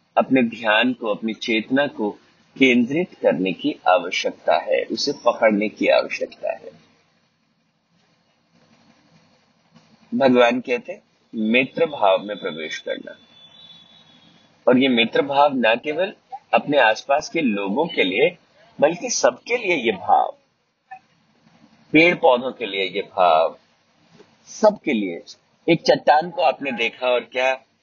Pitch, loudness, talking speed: 140 Hz, -20 LUFS, 120 wpm